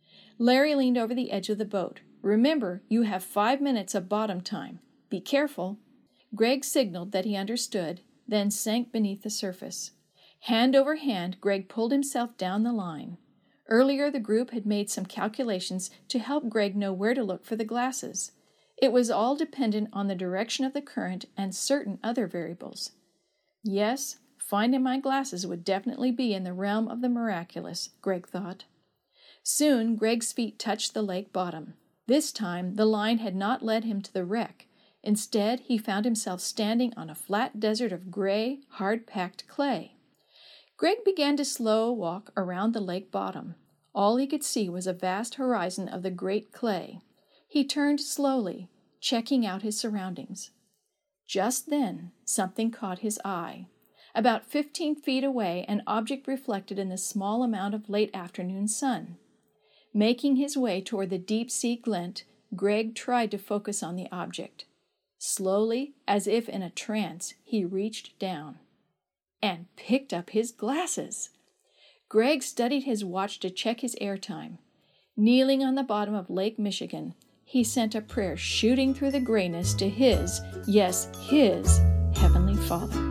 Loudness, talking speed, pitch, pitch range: -28 LUFS, 160 wpm, 215 Hz, 195-250 Hz